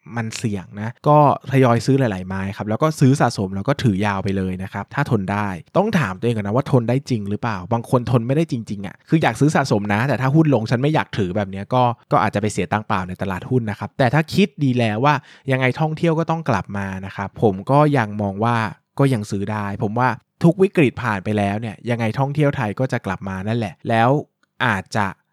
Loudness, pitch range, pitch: -20 LUFS, 105-135 Hz, 120 Hz